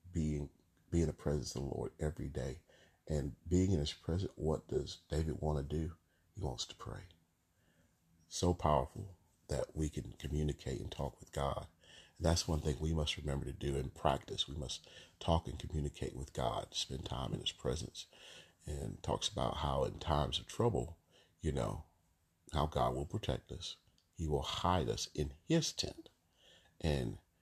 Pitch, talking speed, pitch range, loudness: 80 Hz, 180 wpm, 75-90 Hz, -39 LUFS